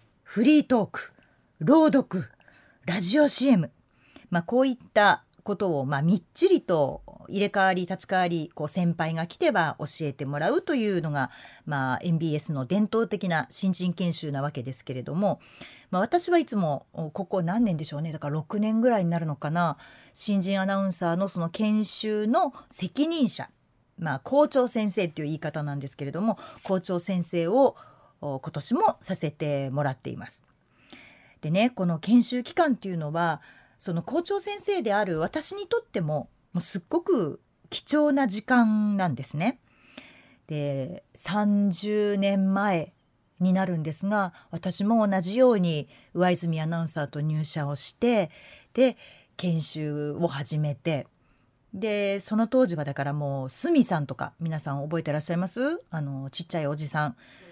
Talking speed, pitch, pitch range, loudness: 305 characters per minute, 180 Hz, 150-215 Hz, -26 LUFS